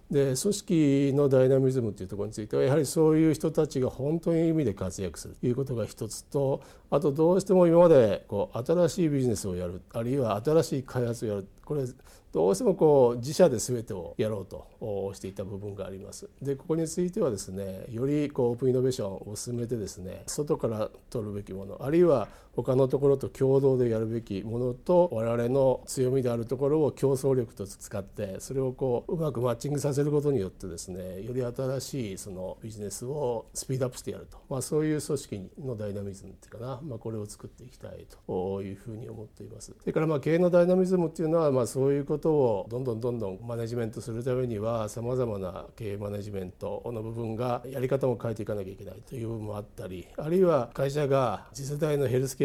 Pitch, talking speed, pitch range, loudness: 125 Hz, 445 characters per minute, 105-140 Hz, -28 LUFS